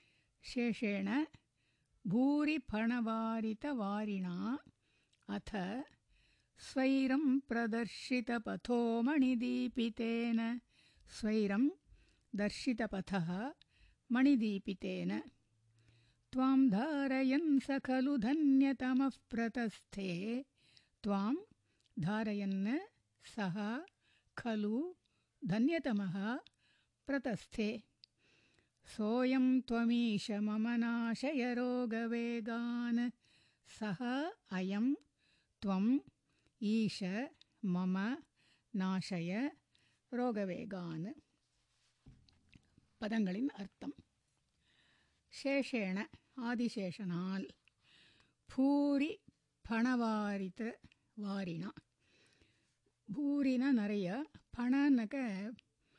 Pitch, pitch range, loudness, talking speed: 235 Hz, 200-260 Hz, -37 LUFS, 40 wpm